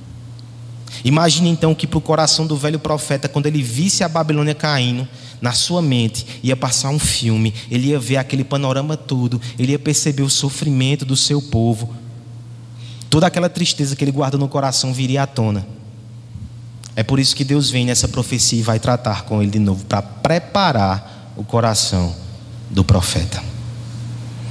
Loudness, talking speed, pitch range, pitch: -17 LUFS, 165 wpm, 115-145 Hz, 125 Hz